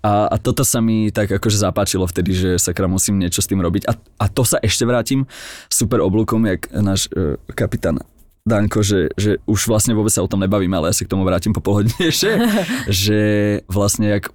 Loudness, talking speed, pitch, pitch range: -17 LUFS, 200 wpm, 105 Hz, 95-110 Hz